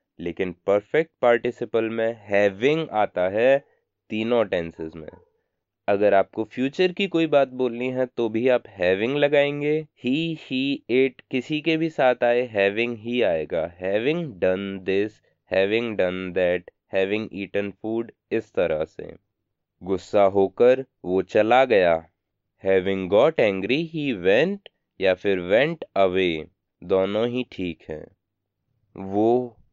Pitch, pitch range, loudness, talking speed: 110 Hz, 95-125 Hz, -23 LUFS, 130 wpm